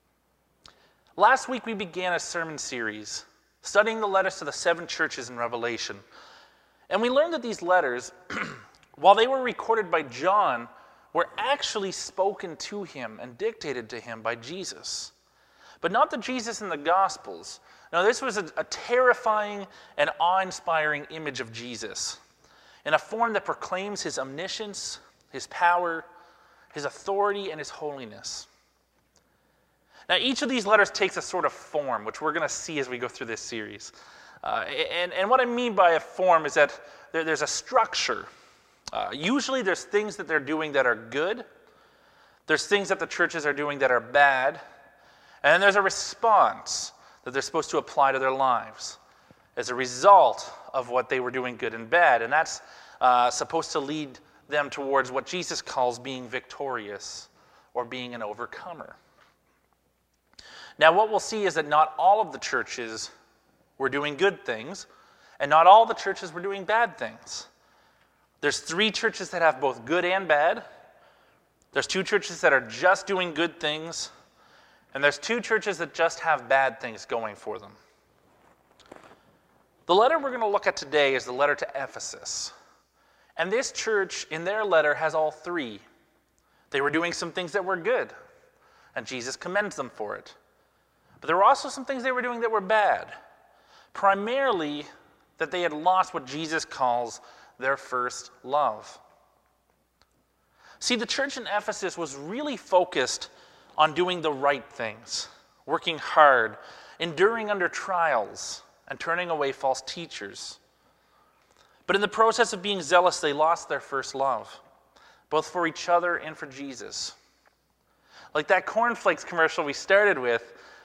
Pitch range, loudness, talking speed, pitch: 145-210 Hz, -26 LUFS, 165 wpm, 175 Hz